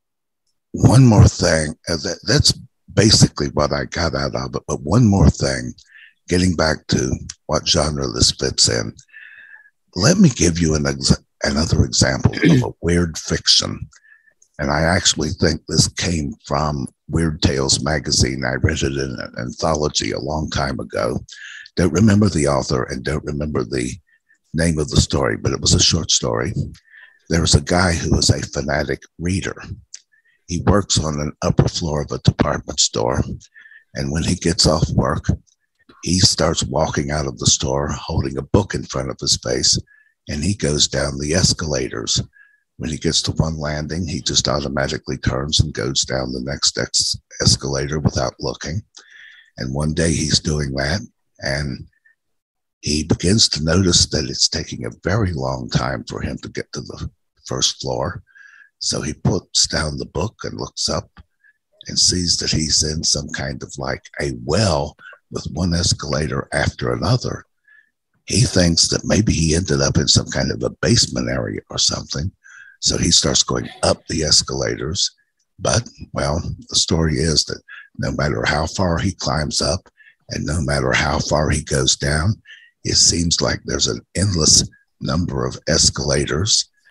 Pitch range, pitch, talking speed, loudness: 70-100 Hz, 80 Hz, 165 wpm, -18 LUFS